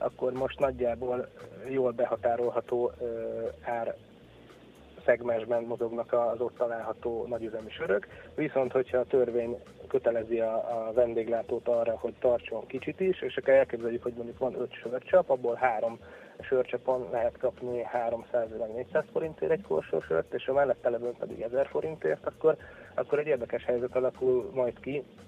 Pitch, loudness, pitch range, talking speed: 120 Hz, -30 LUFS, 115-130 Hz, 135 wpm